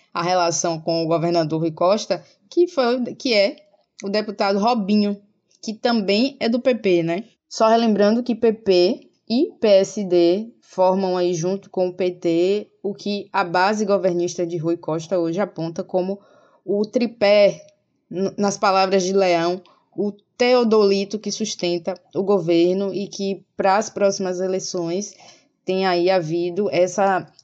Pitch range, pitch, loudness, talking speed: 180-210 Hz, 195 Hz, -20 LUFS, 140 wpm